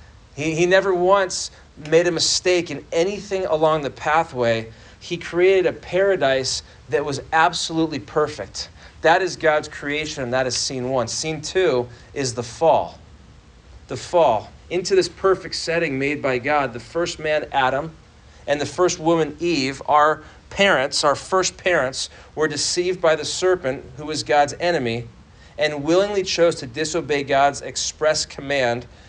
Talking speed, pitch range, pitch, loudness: 155 wpm, 140-175 Hz, 155 Hz, -20 LUFS